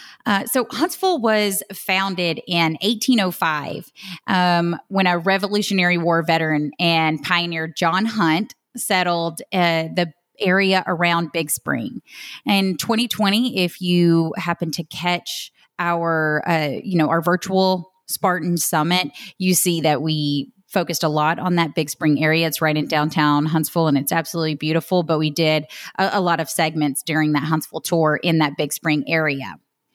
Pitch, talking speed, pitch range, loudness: 170 Hz, 155 wpm, 155-185 Hz, -20 LUFS